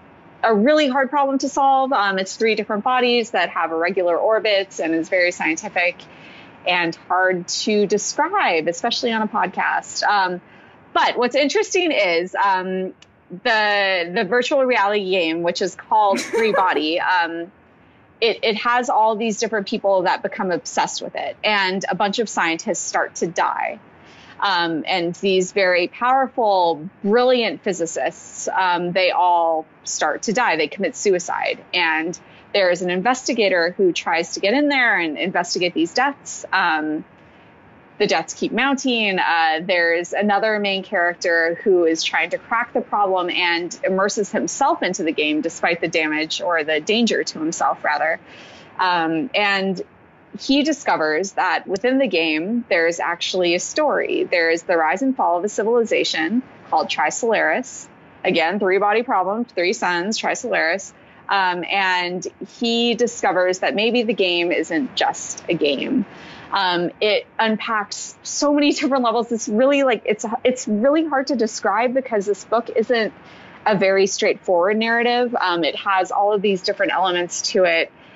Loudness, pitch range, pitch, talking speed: -19 LUFS, 180-245 Hz, 205 Hz, 155 wpm